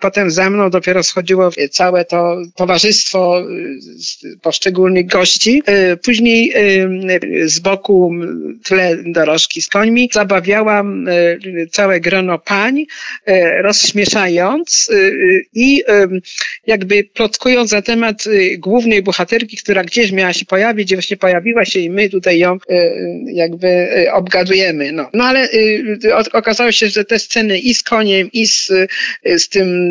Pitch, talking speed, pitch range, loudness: 195 Hz, 120 wpm, 180-220 Hz, -12 LUFS